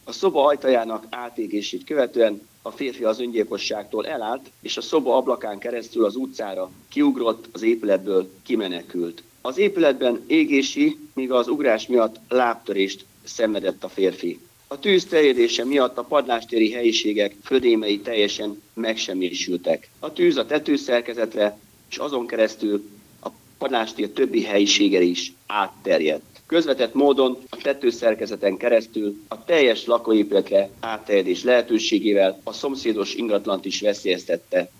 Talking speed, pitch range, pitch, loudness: 120 wpm, 105-165 Hz, 115 Hz, -22 LUFS